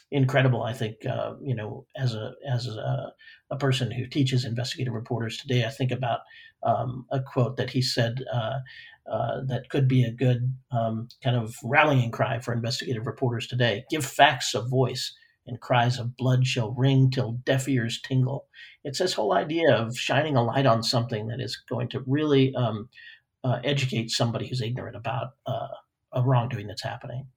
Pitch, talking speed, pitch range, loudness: 130 Hz, 180 wpm, 120-135 Hz, -26 LUFS